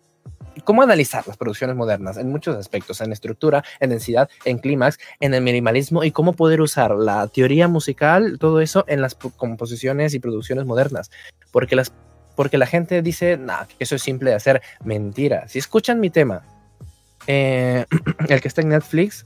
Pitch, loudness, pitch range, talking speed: 135 Hz, -19 LUFS, 120-160 Hz, 175 wpm